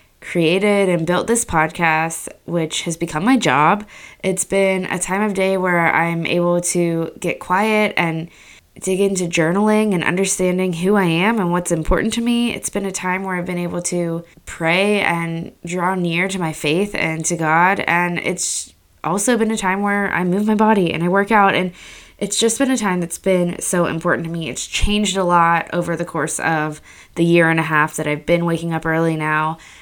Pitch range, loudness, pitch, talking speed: 165-195 Hz, -18 LUFS, 175 Hz, 205 wpm